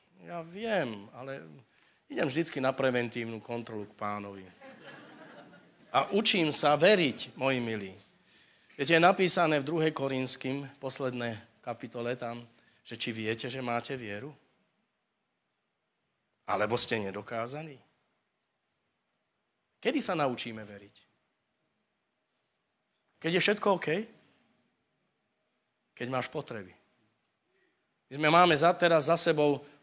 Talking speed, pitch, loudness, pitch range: 105 wpm, 130 Hz, -29 LUFS, 115-155 Hz